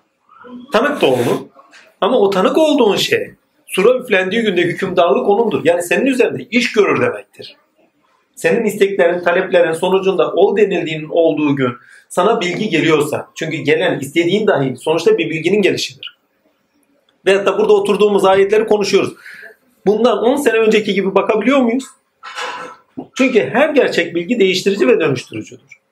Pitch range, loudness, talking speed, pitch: 175-245 Hz, -14 LUFS, 135 wpm, 200 Hz